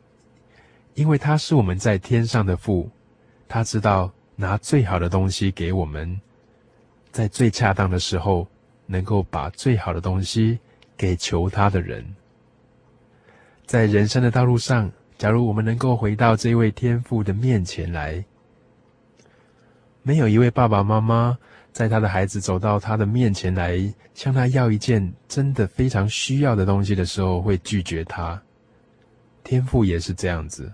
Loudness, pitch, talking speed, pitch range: -21 LUFS, 110 Hz, 225 characters per minute, 95-120 Hz